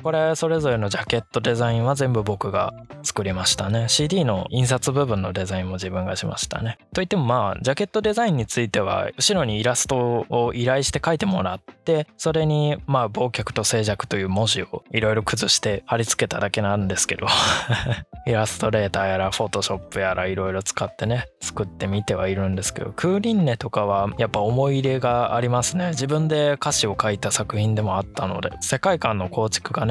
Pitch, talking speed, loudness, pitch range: 115 Hz, 425 characters per minute, -22 LUFS, 100-135 Hz